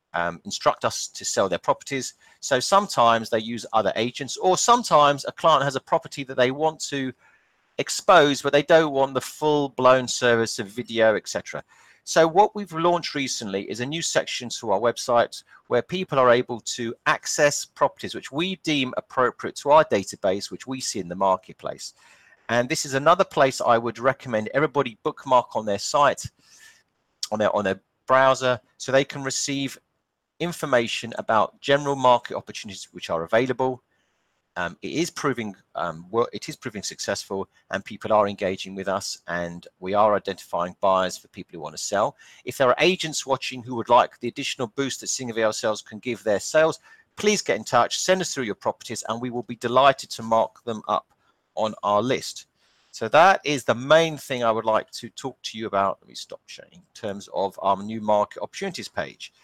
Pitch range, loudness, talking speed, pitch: 115-150 Hz, -23 LUFS, 190 wpm, 130 Hz